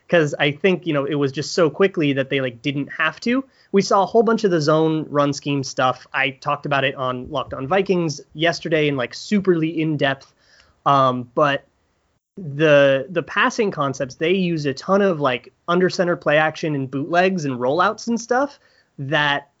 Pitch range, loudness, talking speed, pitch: 140-180 Hz, -20 LUFS, 195 wpm, 150 Hz